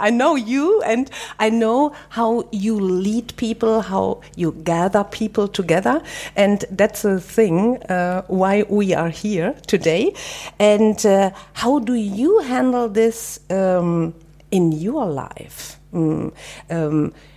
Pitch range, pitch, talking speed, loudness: 175-230 Hz, 205 Hz, 130 wpm, -19 LUFS